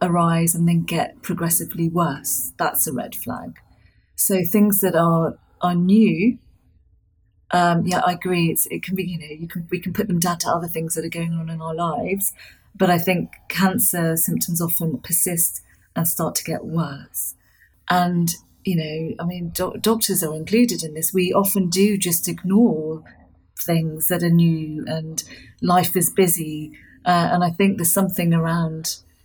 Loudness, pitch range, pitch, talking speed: -20 LUFS, 160-185 Hz, 170 Hz, 180 wpm